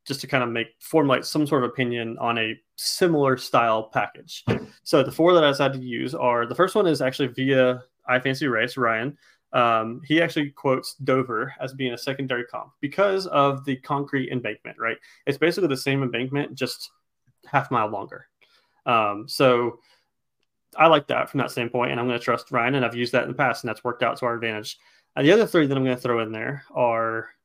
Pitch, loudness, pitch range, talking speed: 130 Hz, -23 LUFS, 120-140 Hz, 215 wpm